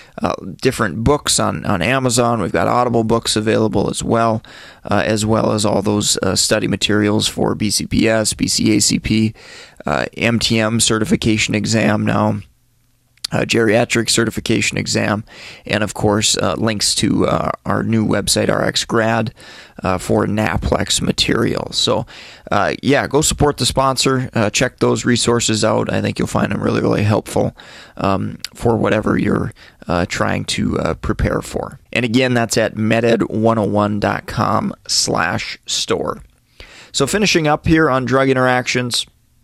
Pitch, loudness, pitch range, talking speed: 110 Hz, -16 LUFS, 105-120 Hz, 140 wpm